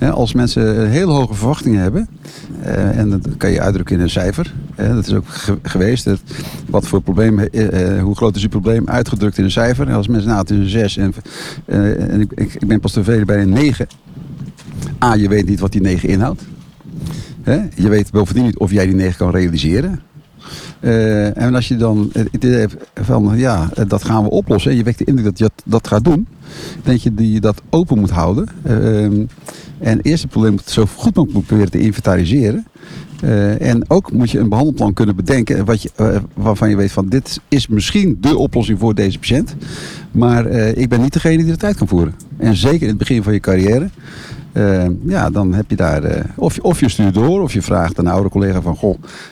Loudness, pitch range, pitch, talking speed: -15 LUFS, 100-125 Hz, 110 Hz, 220 wpm